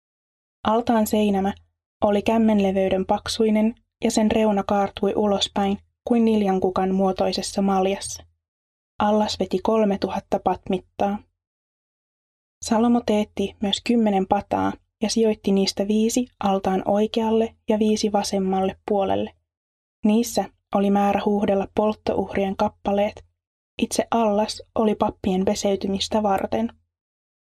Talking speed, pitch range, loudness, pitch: 100 wpm, 190-215 Hz, -22 LUFS, 200 Hz